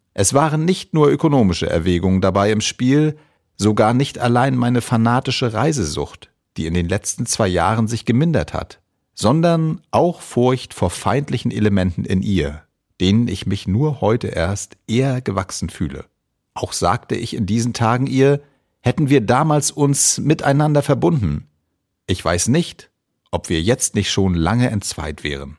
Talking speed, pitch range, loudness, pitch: 150 wpm, 95-140 Hz, -18 LUFS, 115 Hz